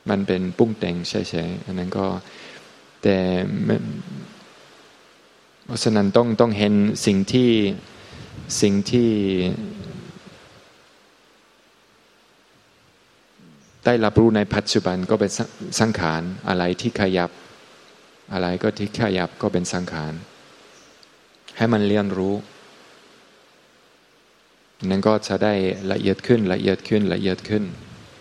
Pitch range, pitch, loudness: 90-110 Hz, 100 Hz, -21 LUFS